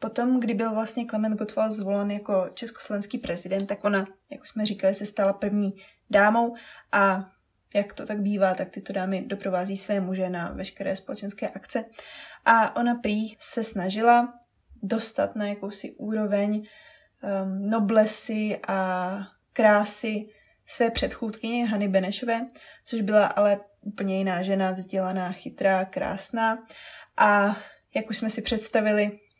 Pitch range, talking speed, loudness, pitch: 195-225 Hz, 135 wpm, -25 LUFS, 210 Hz